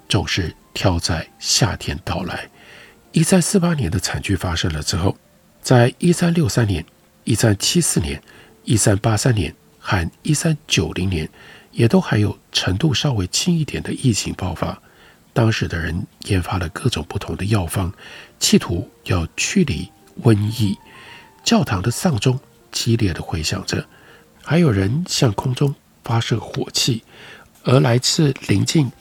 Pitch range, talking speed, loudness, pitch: 95-140 Hz, 220 characters per minute, -19 LUFS, 110 Hz